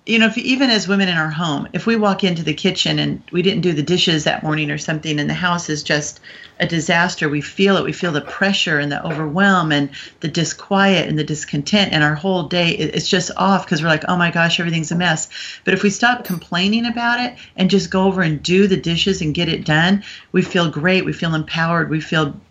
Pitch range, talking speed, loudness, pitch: 155-195 Hz, 245 wpm, -17 LUFS, 175 Hz